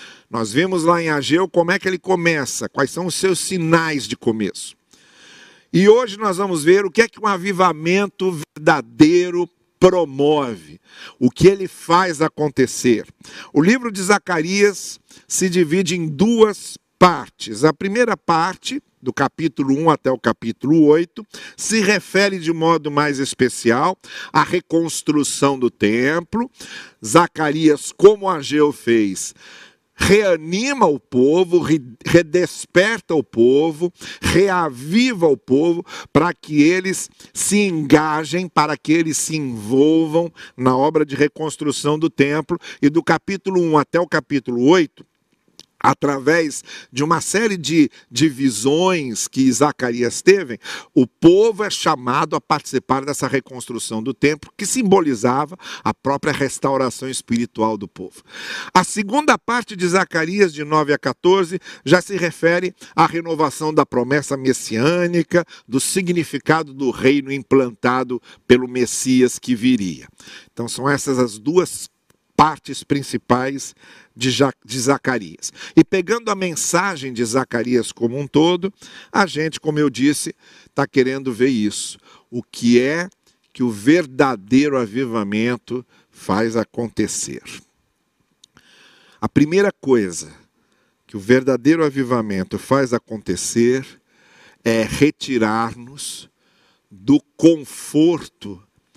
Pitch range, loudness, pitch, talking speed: 130-175 Hz, -18 LUFS, 150 Hz, 125 wpm